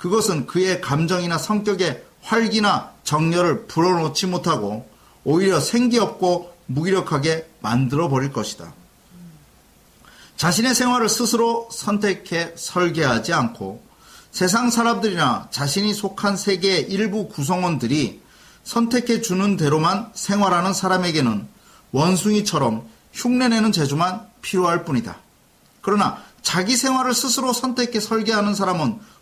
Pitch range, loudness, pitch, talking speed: 160-220 Hz, -20 LUFS, 185 Hz, 290 characters per minute